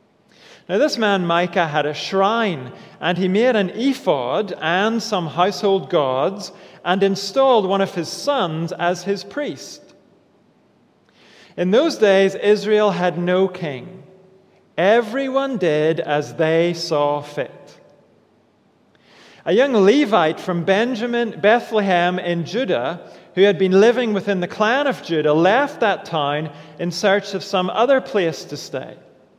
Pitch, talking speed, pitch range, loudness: 195 Hz, 135 wpm, 175-215 Hz, -19 LUFS